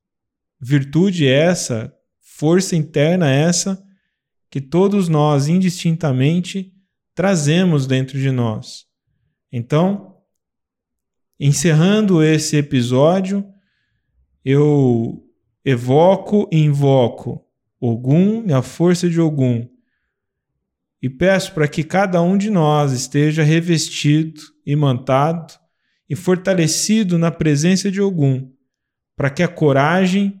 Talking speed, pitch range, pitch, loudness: 95 wpm, 135-185 Hz, 155 Hz, -16 LUFS